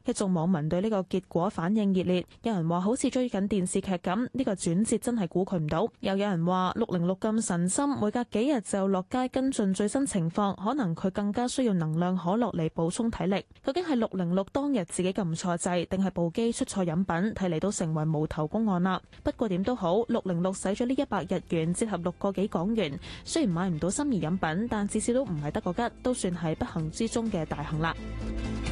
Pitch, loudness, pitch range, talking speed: 195 Hz, -29 LUFS, 175-230 Hz, 325 characters per minute